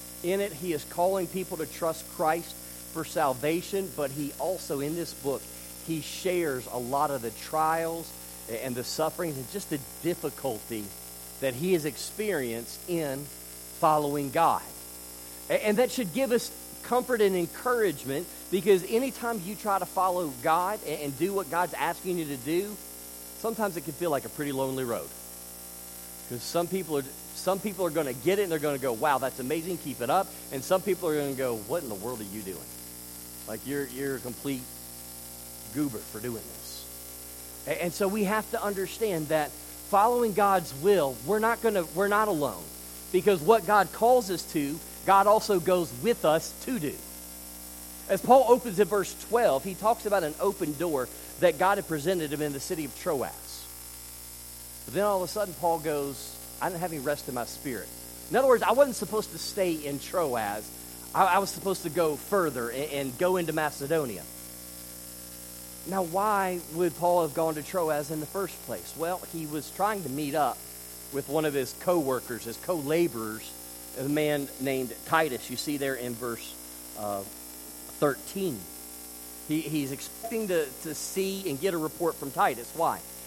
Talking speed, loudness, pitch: 180 wpm, -29 LUFS, 150 Hz